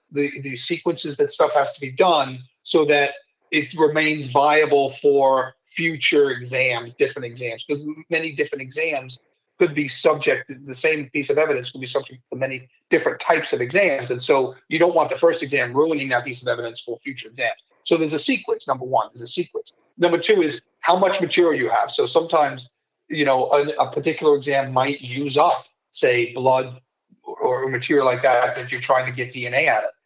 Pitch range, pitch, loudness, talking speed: 130-160 Hz, 140 Hz, -20 LUFS, 200 wpm